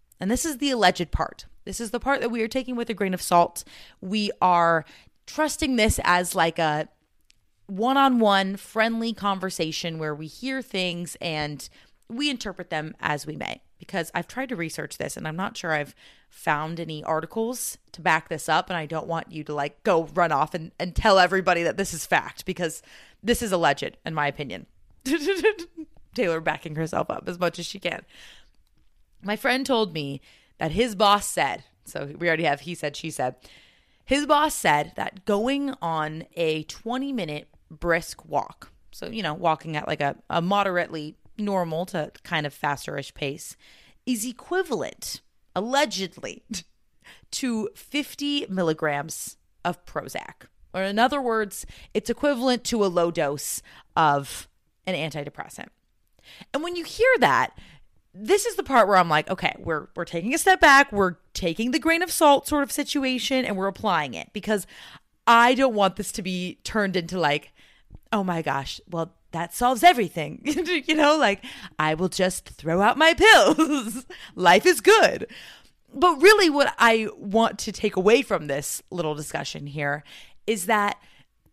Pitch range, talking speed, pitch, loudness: 160-245 Hz, 170 wpm, 190 Hz, -24 LUFS